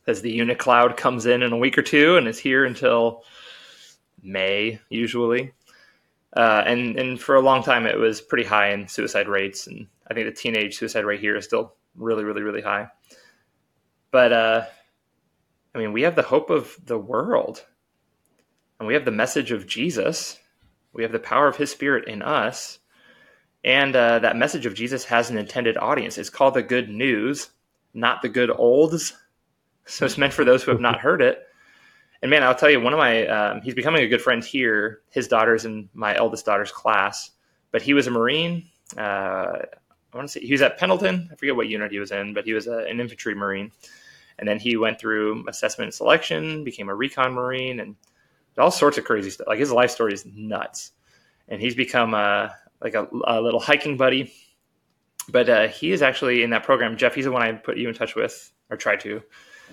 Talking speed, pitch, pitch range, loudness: 205 wpm, 120 Hz, 110-140 Hz, -21 LUFS